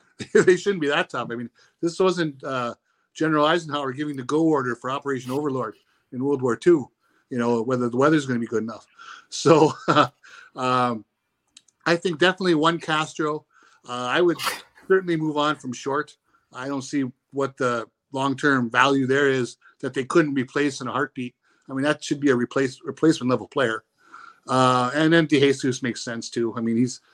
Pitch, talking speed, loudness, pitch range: 140 Hz, 190 wpm, -23 LUFS, 125-155 Hz